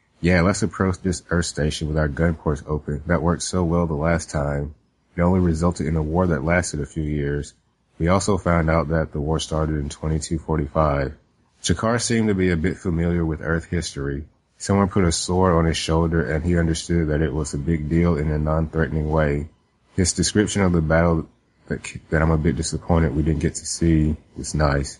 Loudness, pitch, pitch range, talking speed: -22 LUFS, 80 Hz, 75-85 Hz, 210 wpm